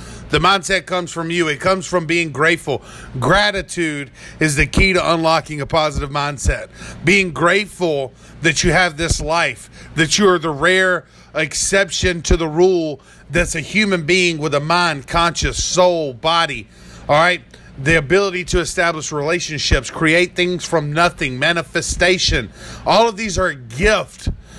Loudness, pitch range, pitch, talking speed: -16 LUFS, 150-180 Hz, 170 Hz, 155 wpm